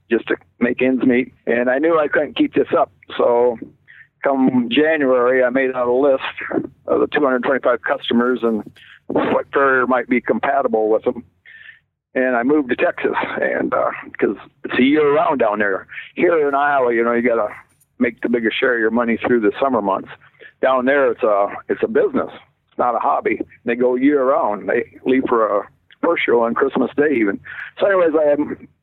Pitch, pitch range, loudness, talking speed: 130 Hz, 120-150 Hz, -18 LUFS, 190 wpm